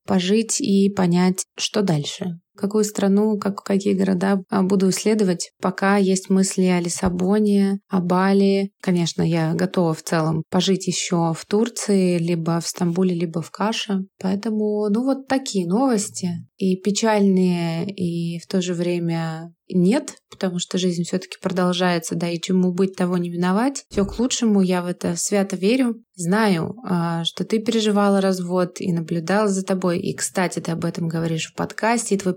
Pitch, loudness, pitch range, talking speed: 190 Hz, -21 LUFS, 175-200 Hz, 160 wpm